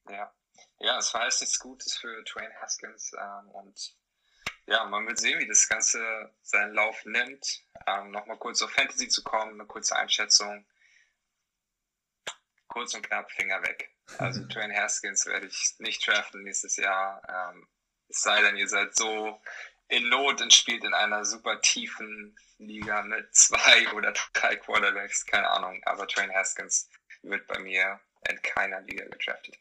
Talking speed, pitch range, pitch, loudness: 160 wpm, 100-110 Hz, 105 Hz, -25 LUFS